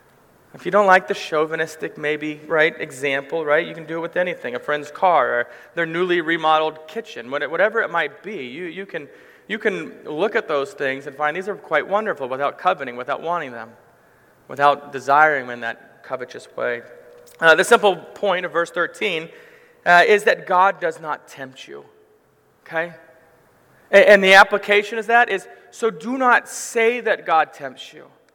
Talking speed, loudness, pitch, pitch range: 180 wpm, -19 LUFS, 175 Hz, 150-205 Hz